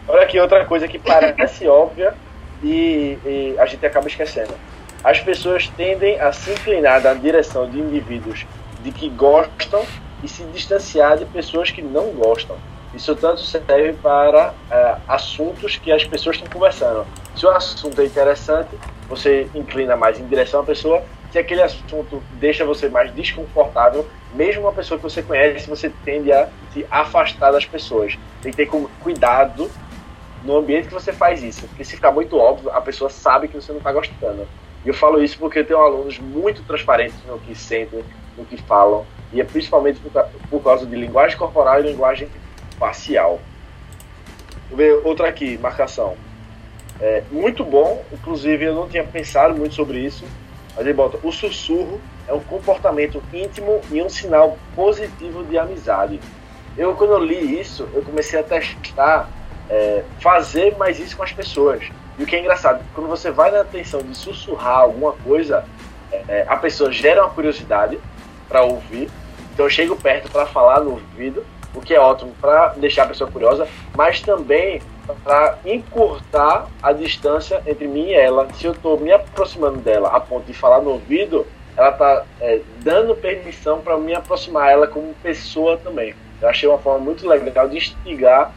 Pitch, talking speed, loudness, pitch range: 150 Hz, 175 wpm, -17 LUFS, 135-185 Hz